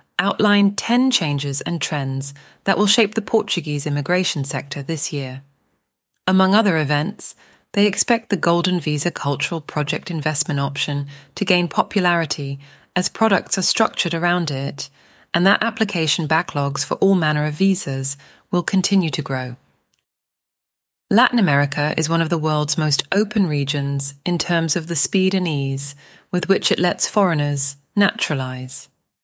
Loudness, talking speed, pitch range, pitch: -19 LUFS, 145 wpm, 145-190 Hz, 165 Hz